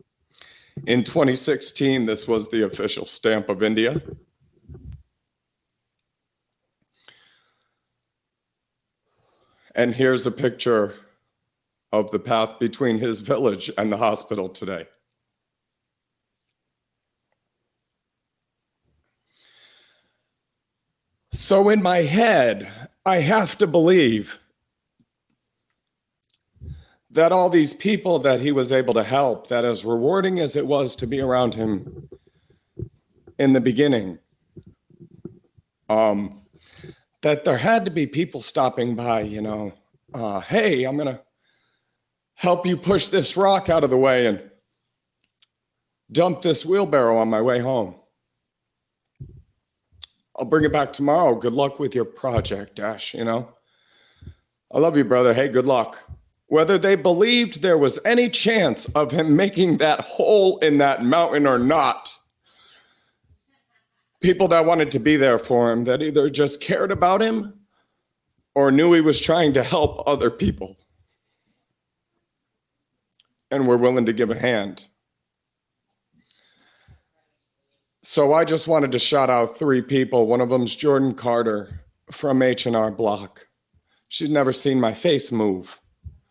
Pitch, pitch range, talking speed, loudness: 135 Hz, 115-160 Hz, 125 wpm, -20 LUFS